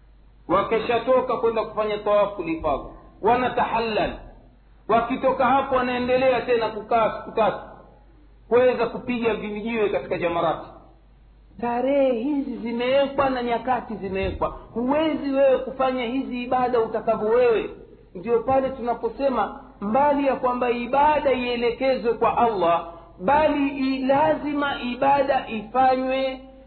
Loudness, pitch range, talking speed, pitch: -23 LUFS, 225-265 Hz, 100 wpm, 245 Hz